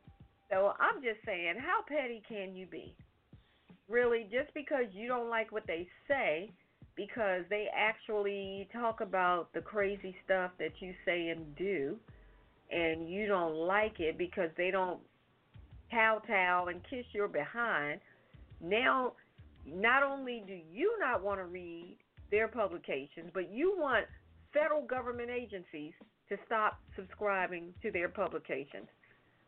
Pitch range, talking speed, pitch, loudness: 175-230 Hz, 140 wpm, 195 Hz, -35 LUFS